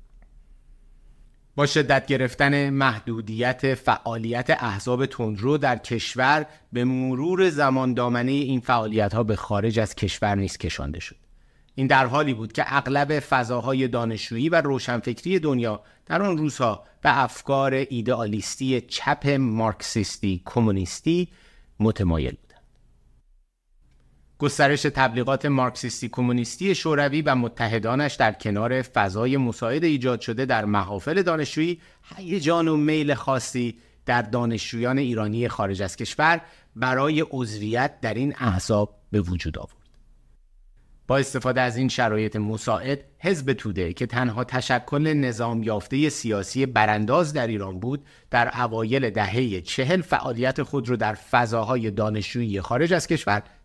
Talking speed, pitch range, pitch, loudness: 125 wpm, 110-140 Hz, 125 Hz, -24 LUFS